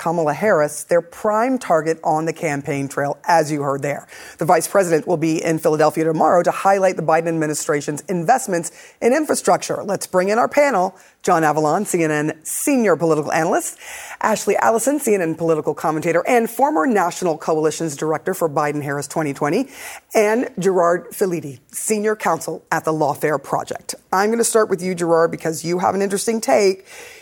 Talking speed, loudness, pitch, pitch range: 165 wpm, -19 LUFS, 170 Hz, 155-205 Hz